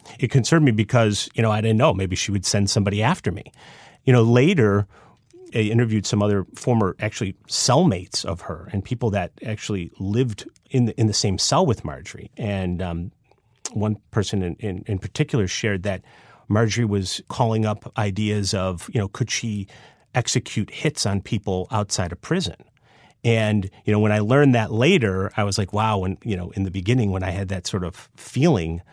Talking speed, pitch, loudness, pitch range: 195 wpm, 105 Hz, -22 LUFS, 100-120 Hz